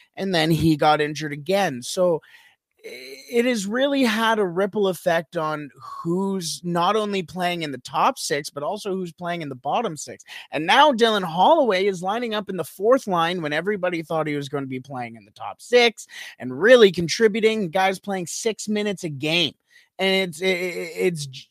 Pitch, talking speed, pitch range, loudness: 185 Hz, 190 wpm, 160-215 Hz, -22 LUFS